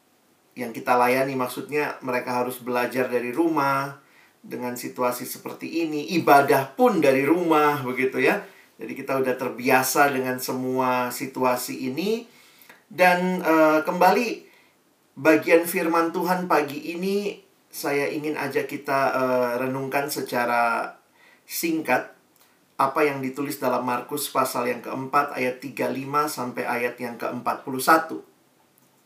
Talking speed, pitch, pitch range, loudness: 120 wpm, 135 Hz, 125-155 Hz, -23 LUFS